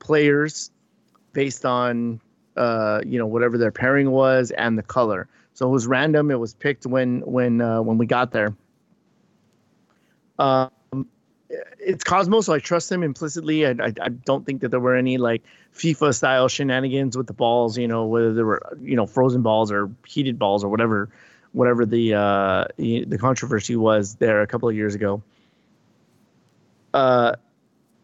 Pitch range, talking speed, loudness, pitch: 115-135 Hz, 170 wpm, -21 LUFS, 125 Hz